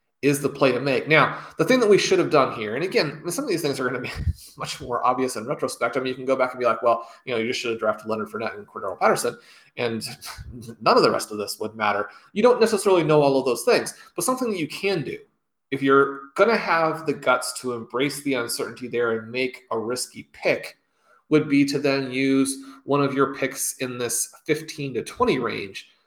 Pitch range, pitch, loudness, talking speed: 125-150 Hz, 135 Hz, -23 LUFS, 245 wpm